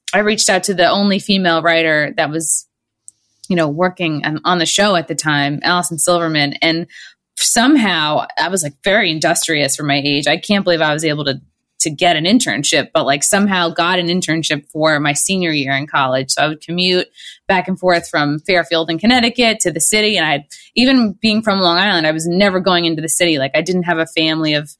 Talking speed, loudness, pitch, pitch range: 220 wpm, -14 LUFS, 165 Hz, 150-185 Hz